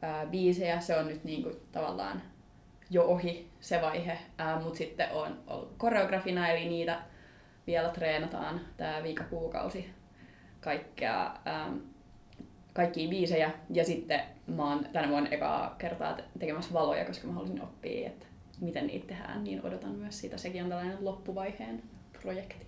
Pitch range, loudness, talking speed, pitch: 155-175 Hz, -34 LUFS, 145 wpm, 165 Hz